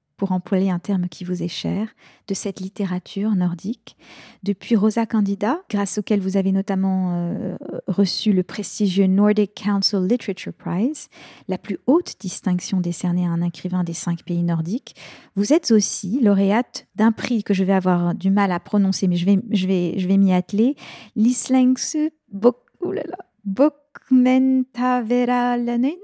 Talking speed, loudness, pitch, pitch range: 145 wpm, -21 LUFS, 200 Hz, 185-230 Hz